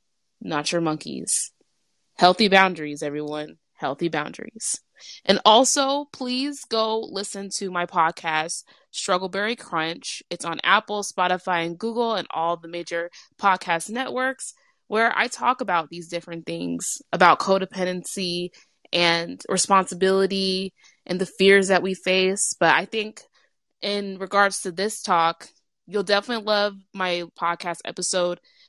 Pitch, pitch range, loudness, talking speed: 190 Hz, 170-210 Hz, -23 LUFS, 130 wpm